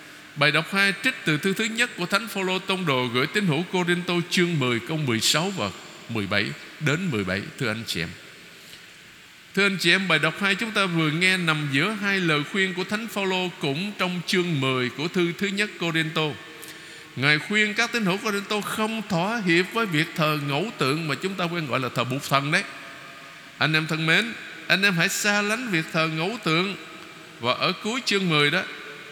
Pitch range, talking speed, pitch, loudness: 155-195 Hz, 210 wpm, 175 Hz, -23 LUFS